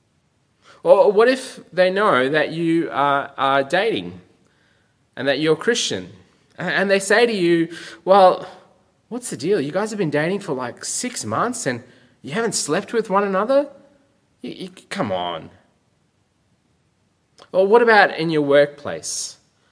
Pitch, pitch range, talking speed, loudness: 185 Hz, 145-225 Hz, 150 wpm, -19 LUFS